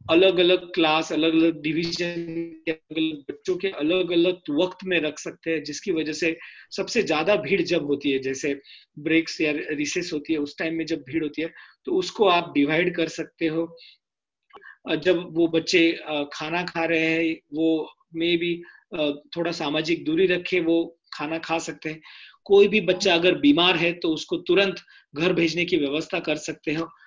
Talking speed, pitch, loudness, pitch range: 180 wpm, 165 Hz, -23 LUFS, 160-180 Hz